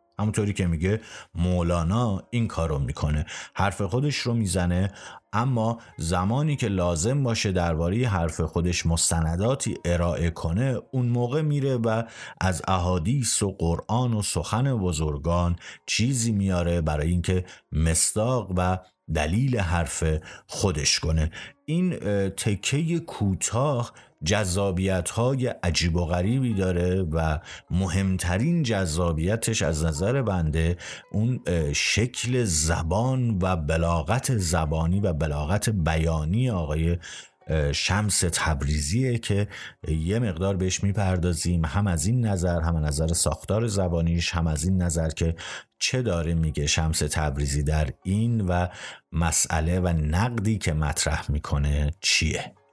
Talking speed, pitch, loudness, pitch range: 120 wpm, 90 Hz, -25 LUFS, 80-110 Hz